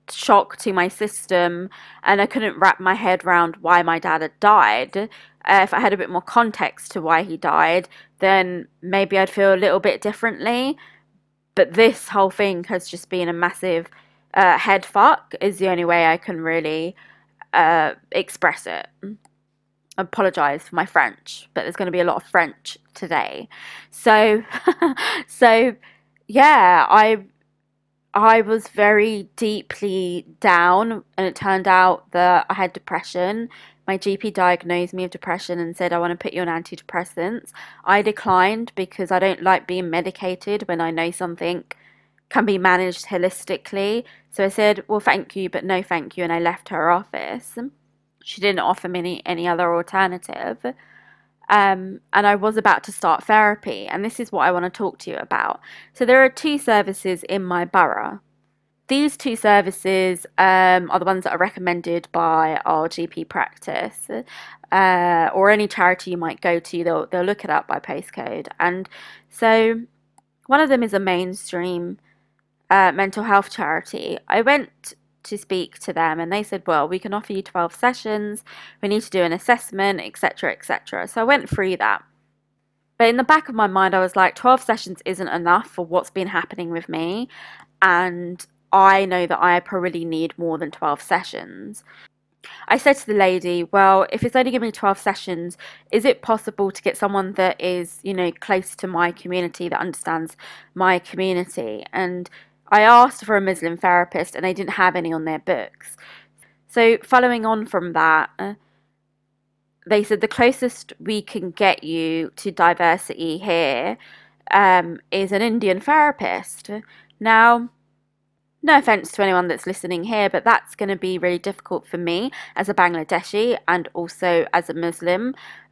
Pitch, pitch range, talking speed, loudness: 190 Hz, 175-210 Hz, 175 wpm, -19 LUFS